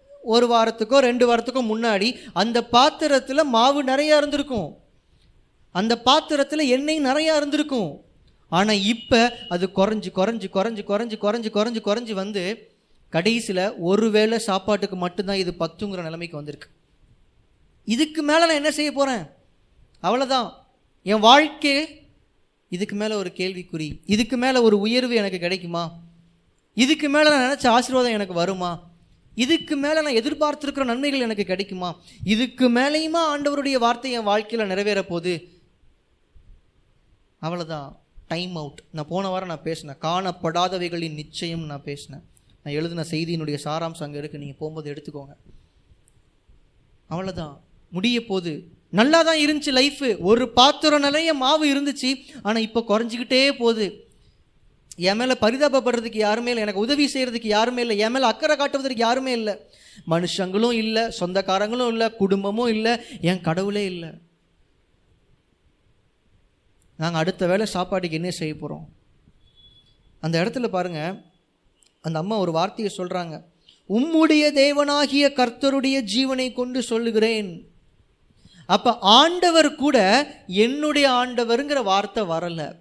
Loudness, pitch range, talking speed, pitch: -21 LUFS, 180-255 Hz, 120 wpm, 220 Hz